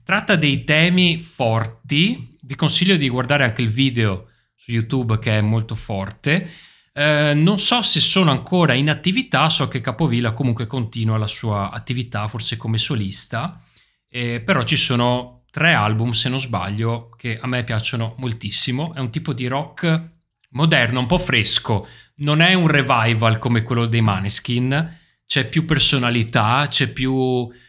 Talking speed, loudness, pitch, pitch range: 155 wpm, -18 LUFS, 130 Hz, 115-155 Hz